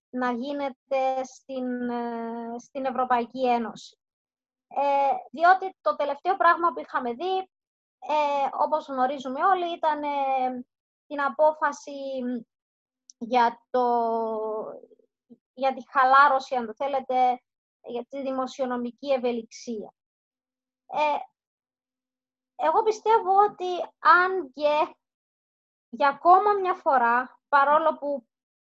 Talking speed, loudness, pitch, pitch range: 95 wpm, -25 LUFS, 270 Hz, 250-310 Hz